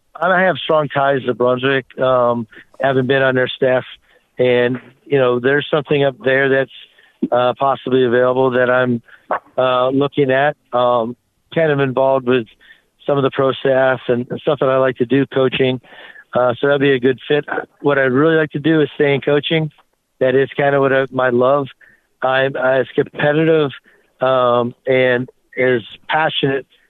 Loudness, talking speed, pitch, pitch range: -16 LUFS, 175 wpm, 130 Hz, 125-140 Hz